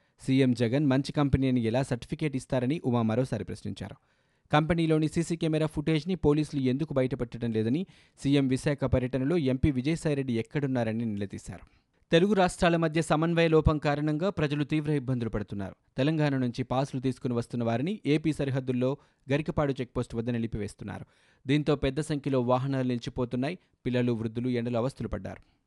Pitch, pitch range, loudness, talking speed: 130 Hz, 120-150 Hz, -28 LUFS, 130 wpm